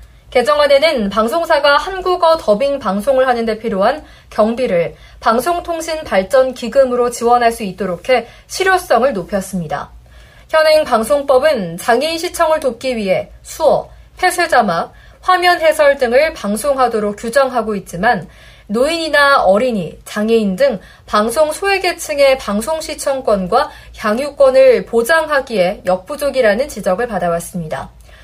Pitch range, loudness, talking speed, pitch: 210-305 Hz, -14 LUFS, 300 characters per minute, 255 Hz